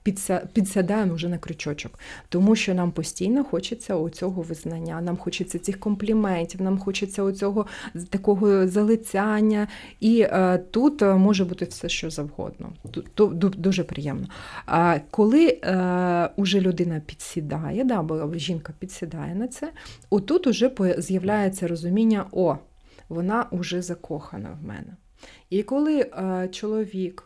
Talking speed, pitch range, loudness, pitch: 130 wpm, 170-210 Hz, -24 LUFS, 185 Hz